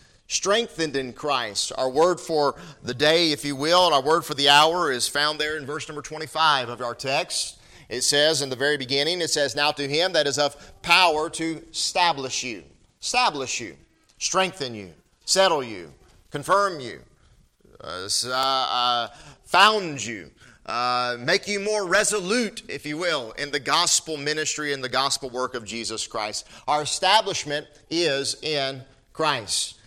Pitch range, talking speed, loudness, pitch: 130-160 Hz, 165 wpm, -22 LUFS, 145 Hz